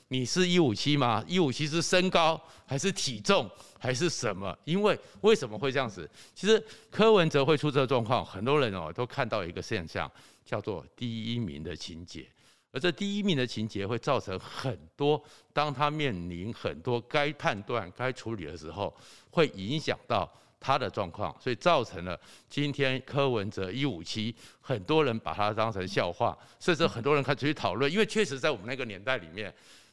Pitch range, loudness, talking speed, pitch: 105-150 Hz, -30 LUFS, 280 characters per minute, 130 Hz